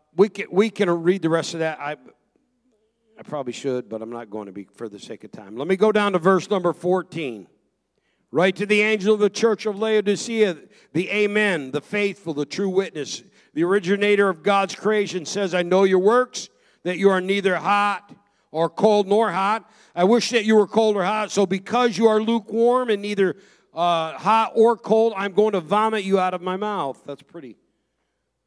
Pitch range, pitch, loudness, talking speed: 180-215 Hz, 200 Hz, -21 LUFS, 205 wpm